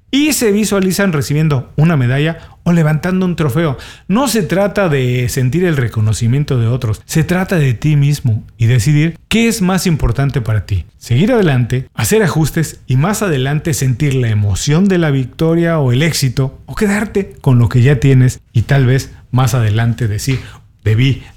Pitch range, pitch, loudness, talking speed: 125-170 Hz, 140 Hz, -14 LUFS, 175 wpm